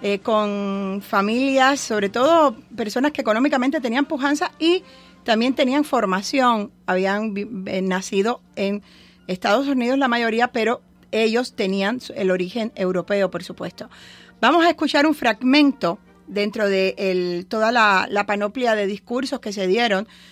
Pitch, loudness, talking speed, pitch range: 220 Hz, -20 LUFS, 135 wpm, 195-265 Hz